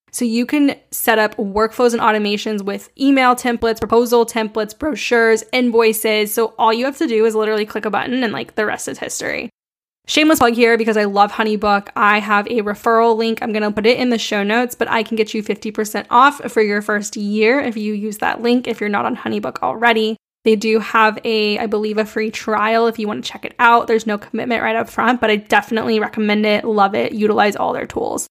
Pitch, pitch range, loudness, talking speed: 225 Hz, 215-235 Hz, -16 LUFS, 225 wpm